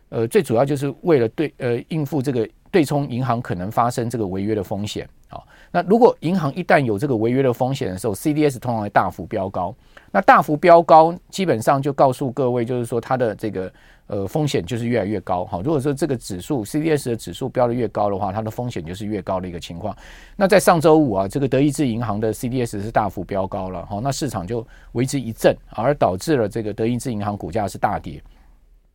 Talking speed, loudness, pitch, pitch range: 355 characters per minute, -20 LUFS, 120 Hz, 105-145 Hz